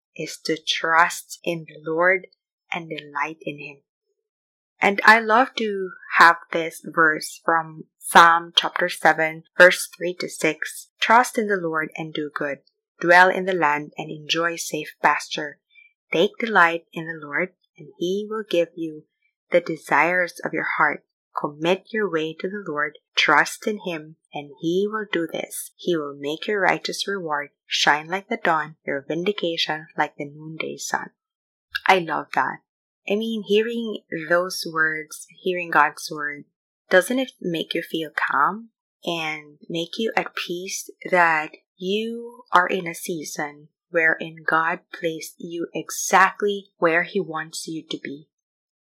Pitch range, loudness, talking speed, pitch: 160-200 Hz, -22 LUFS, 150 wpm, 170 Hz